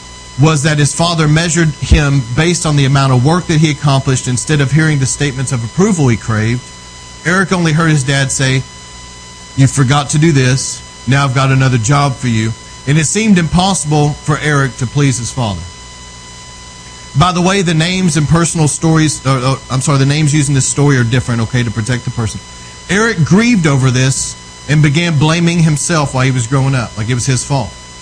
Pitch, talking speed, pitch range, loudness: 140 Hz, 200 wpm, 125-155 Hz, -12 LUFS